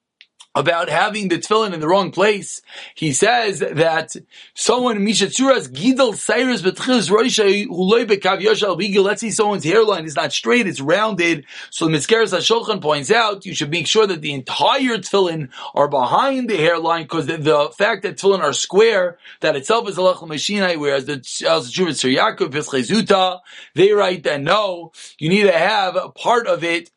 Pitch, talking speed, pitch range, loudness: 195 Hz, 145 wpm, 165-220 Hz, -17 LUFS